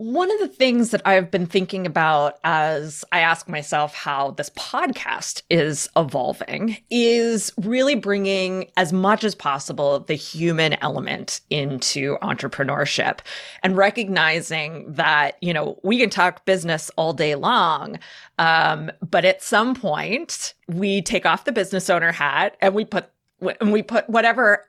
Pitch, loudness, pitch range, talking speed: 185 Hz, -20 LUFS, 160-215 Hz, 150 wpm